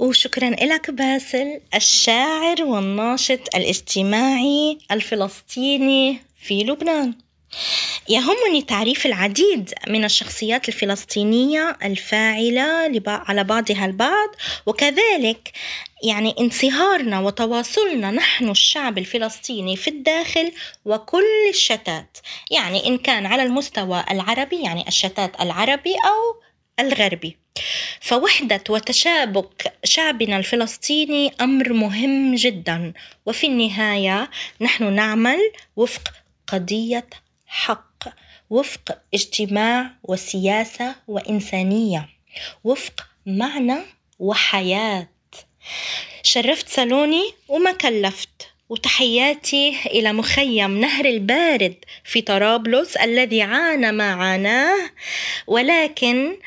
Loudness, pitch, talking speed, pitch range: -19 LUFS, 240 Hz, 85 wpm, 210-280 Hz